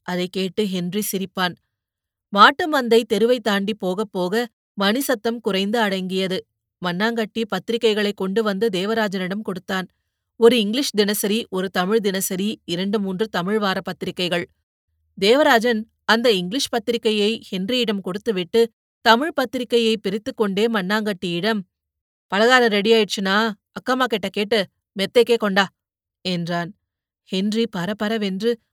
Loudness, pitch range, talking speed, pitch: -20 LUFS, 190-230 Hz, 105 wpm, 210 Hz